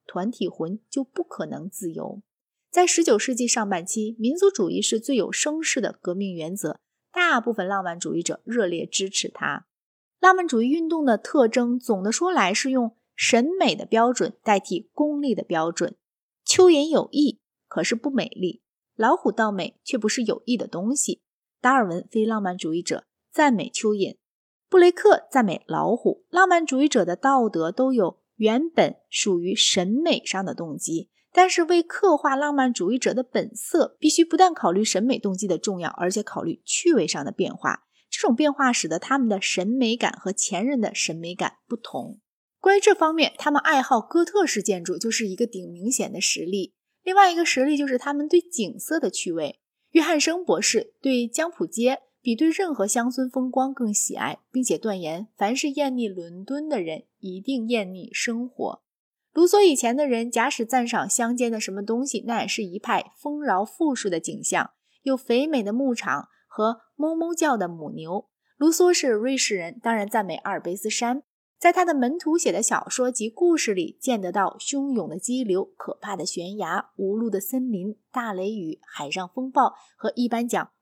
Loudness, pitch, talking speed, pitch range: -23 LUFS, 240 Hz, 270 characters per minute, 200-290 Hz